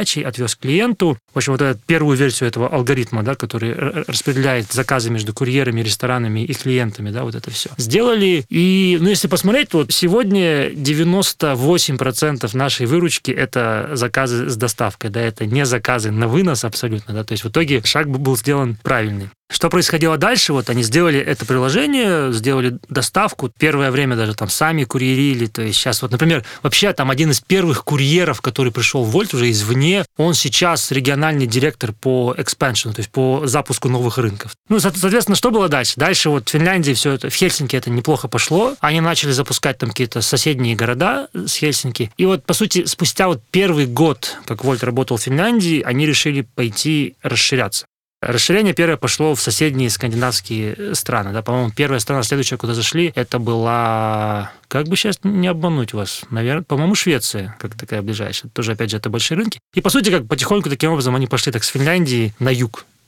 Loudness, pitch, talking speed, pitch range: -17 LUFS, 135 Hz, 180 wpm, 120-160 Hz